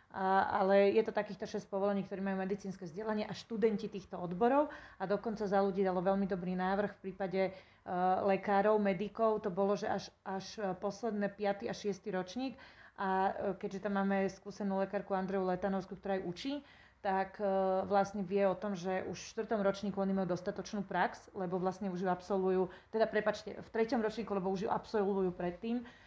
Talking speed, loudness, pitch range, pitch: 185 wpm, -35 LUFS, 190-210 Hz, 195 Hz